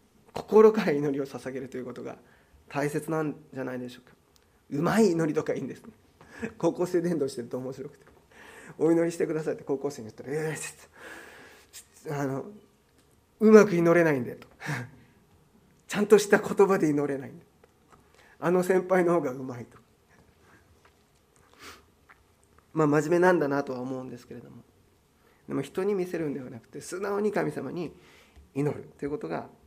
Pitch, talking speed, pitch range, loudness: 145 Hz, 335 characters per minute, 130-175 Hz, -27 LUFS